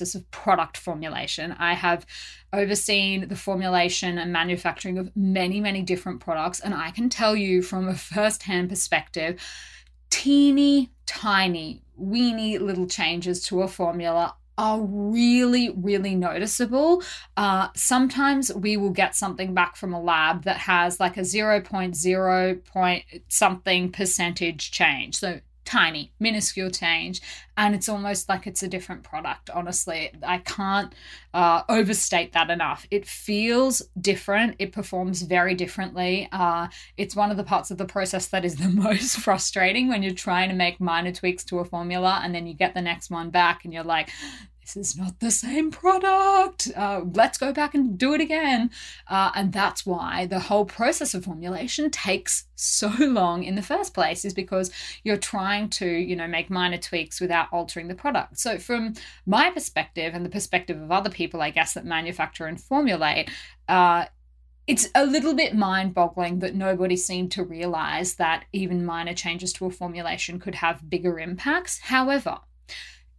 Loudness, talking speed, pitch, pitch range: -24 LUFS, 165 wpm, 185 Hz, 175-210 Hz